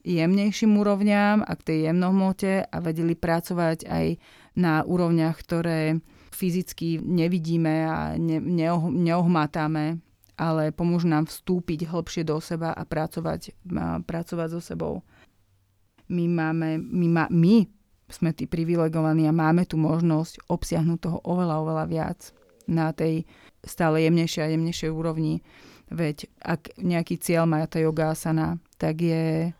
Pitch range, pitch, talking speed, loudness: 160-175 Hz, 165 Hz, 130 wpm, -25 LUFS